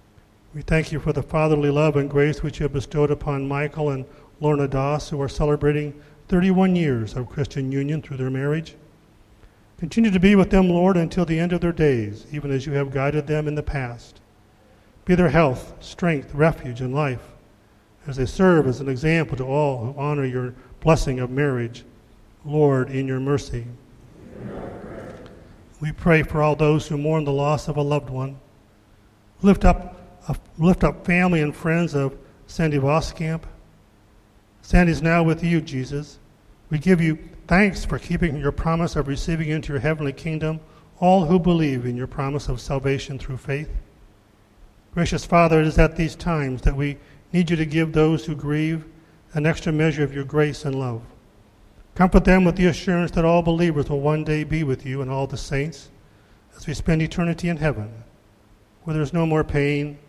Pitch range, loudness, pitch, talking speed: 130-160 Hz, -22 LUFS, 145 Hz, 185 wpm